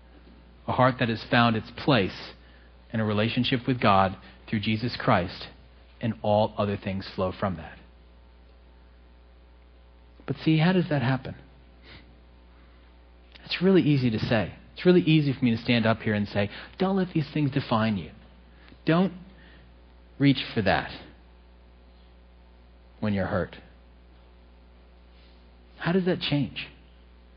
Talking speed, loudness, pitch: 135 wpm, -26 LUFS, 75 Hz